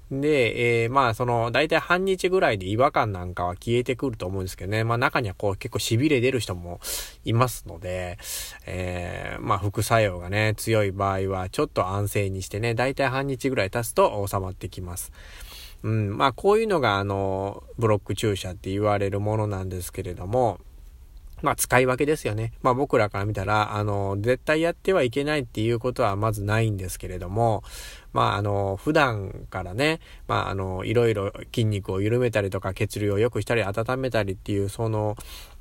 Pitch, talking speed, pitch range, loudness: 105 Hz, 385 characters per minute, 95-125 Hz, -25 LUFS